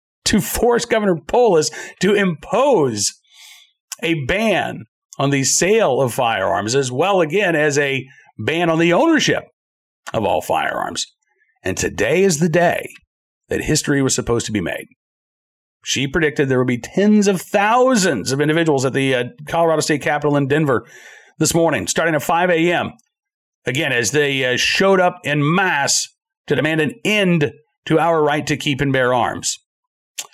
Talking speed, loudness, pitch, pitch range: 160 wpm, -17 LUFS, 155 Hz, 140-185 Hz